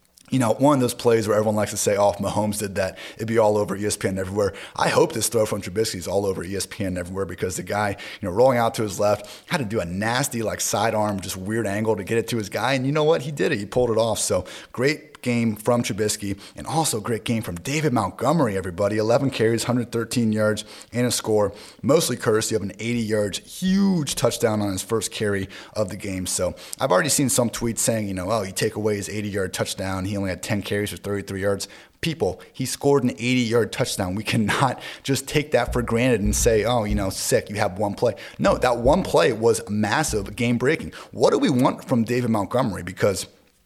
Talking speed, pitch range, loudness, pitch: 235 wpm, 100-120 Hz, -23 LUFS, 110 Hz